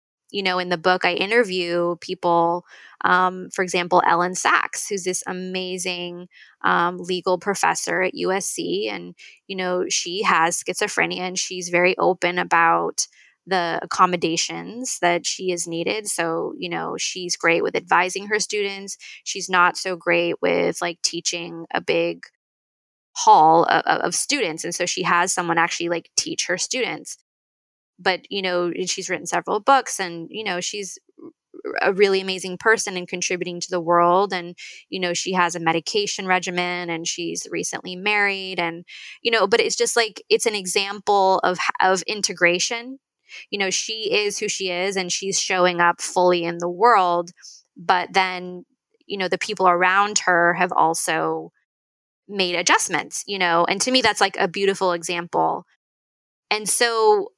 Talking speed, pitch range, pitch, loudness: 160 wpm, 175-200 Hz, 185 Hz, -21 LUFS